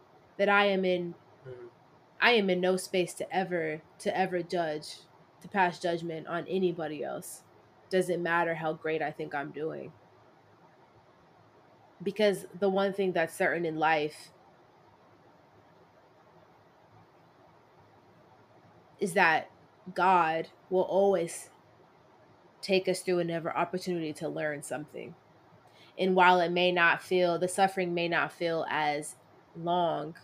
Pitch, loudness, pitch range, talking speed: 175 Hz, -29 LUFS, 160-185 Hz, 125 wpm